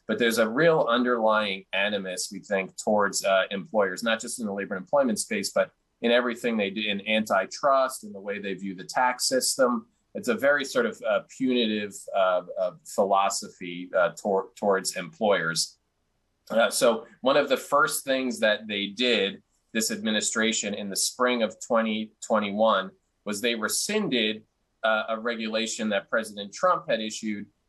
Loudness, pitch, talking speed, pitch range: -26 LUFS, 110 Hz, 165 wpm, 100-125 Hz